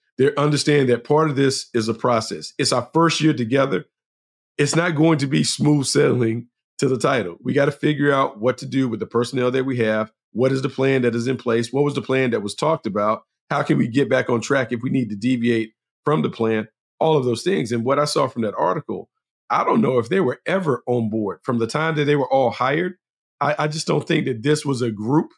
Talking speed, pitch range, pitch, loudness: 255 wpm, 120-145 Hz, 130 Hz, -20 LUFS